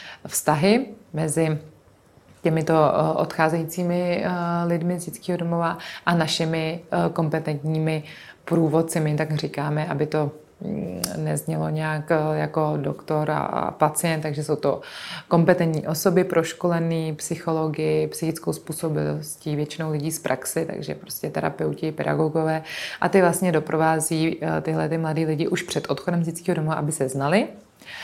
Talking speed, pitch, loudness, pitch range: 120 wpm, 160 Hz, -24 LUFS, 155-170 Hz